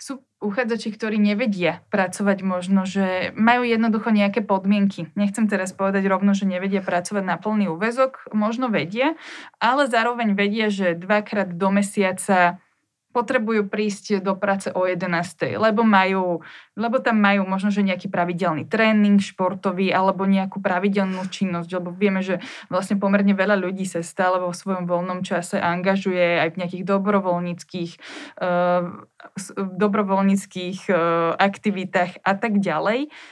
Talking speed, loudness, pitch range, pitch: 135 wpm, -21 LUFS, 185-210 Hz, 195 Hz